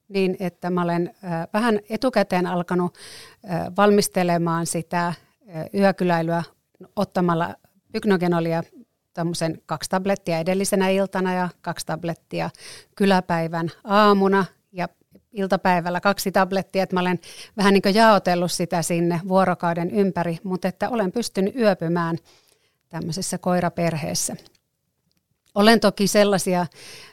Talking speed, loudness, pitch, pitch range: 105 wpm, -22 LUFS, 185 Hz, 170-200 Hz